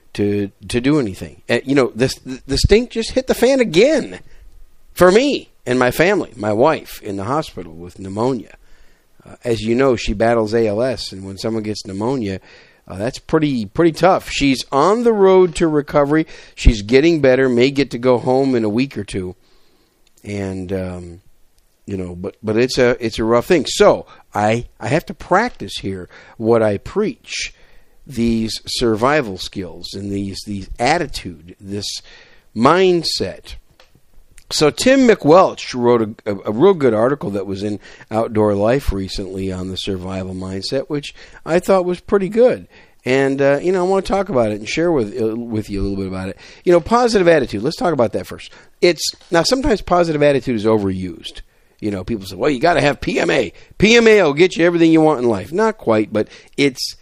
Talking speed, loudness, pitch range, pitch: 190 wpm, -17 LUFS, 100-150 Hz, 115 Hz